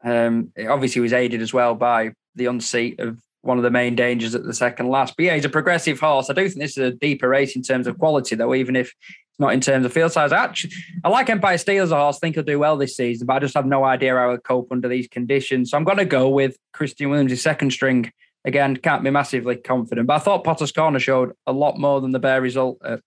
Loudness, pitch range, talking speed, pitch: -20 LUFS, 125-145 Hz, 270 wpm, 130 Hz